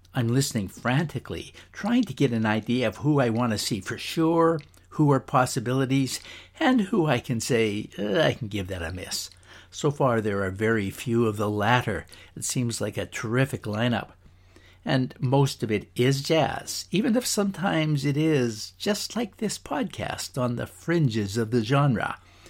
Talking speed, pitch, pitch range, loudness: 180 wpm, 120 Hz, 105-145 Hz, -26 LUFS